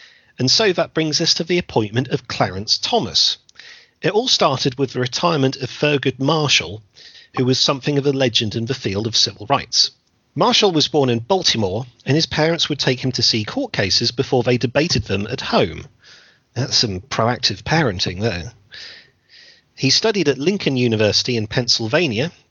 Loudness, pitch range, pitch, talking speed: -18 LUFS, 115-150 Hz, 130 Hz, 175 wpm